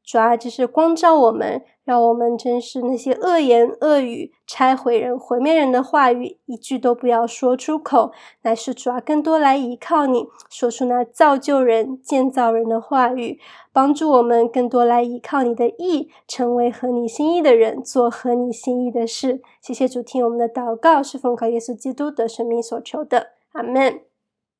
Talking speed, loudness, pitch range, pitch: 265 characters per minute, -18 LUFS, 235-275 Hz, 250 Hz